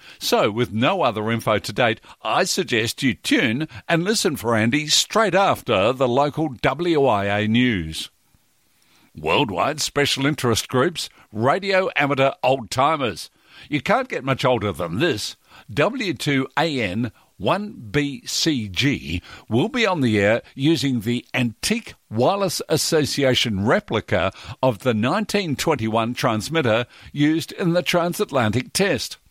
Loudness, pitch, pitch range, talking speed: -21 LUFS, 130 Hz, 115-150 Hz, 115 wpm